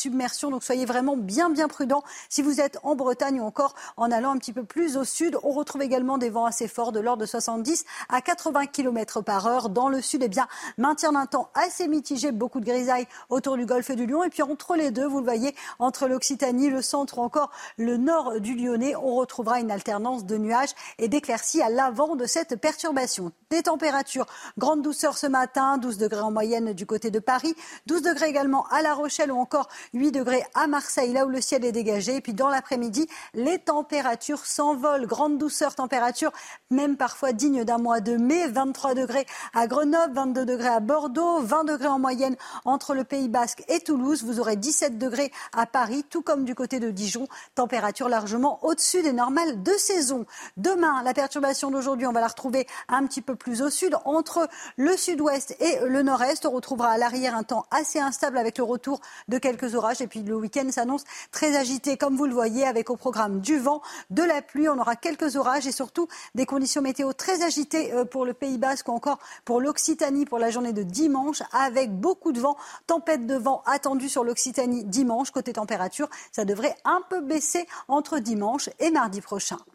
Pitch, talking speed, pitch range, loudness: 270 Hz, 205 wpm, 245-295 Hz, -25 LUFS